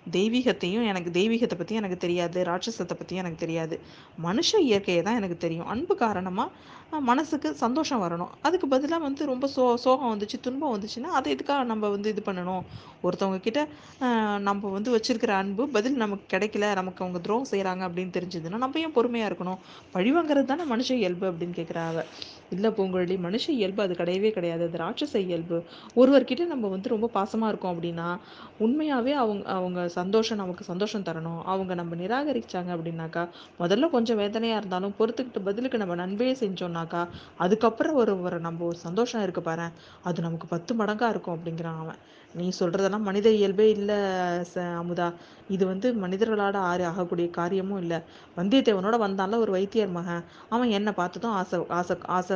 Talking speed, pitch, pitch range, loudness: 155 wpm, 195 Hz, 175-230 Hz, -27 LUFS